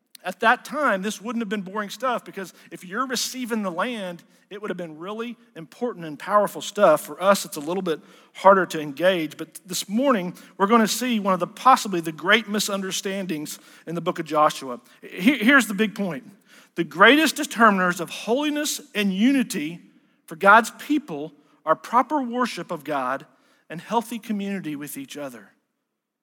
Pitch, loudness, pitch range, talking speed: 200 Hz, -22 LUFS, 170-235 Hz, 175 wpm